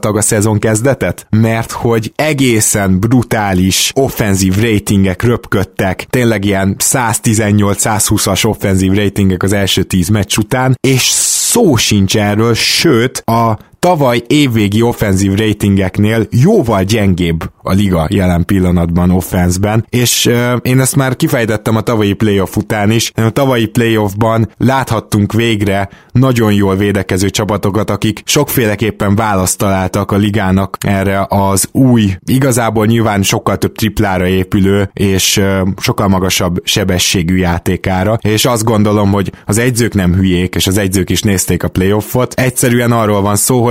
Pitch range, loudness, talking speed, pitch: 95-115 Hz, -11 LUFS, 135 wpm, 105 Hz